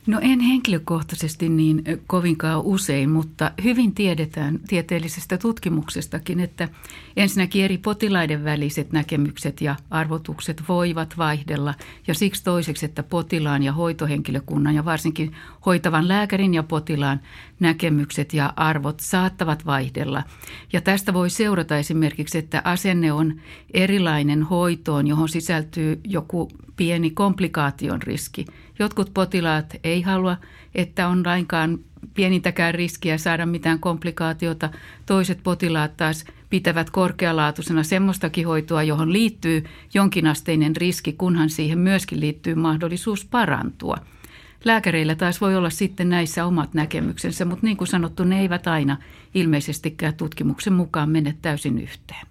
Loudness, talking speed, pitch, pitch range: -22 LUFS, 120 wpm, 165 Hz, 155-180 Hz